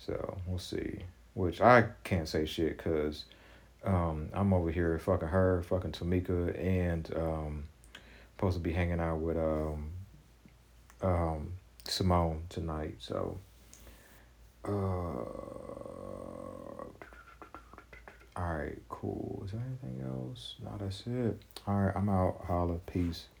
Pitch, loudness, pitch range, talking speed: 90 Hz, -34 LUFS, 80-100 Hz, 125 wpm